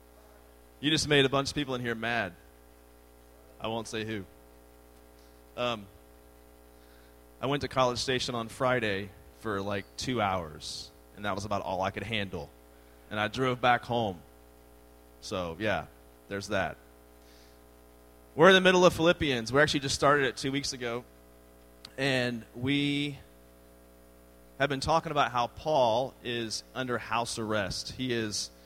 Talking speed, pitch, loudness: 150 wpm, 100 Hz, -29 LUFS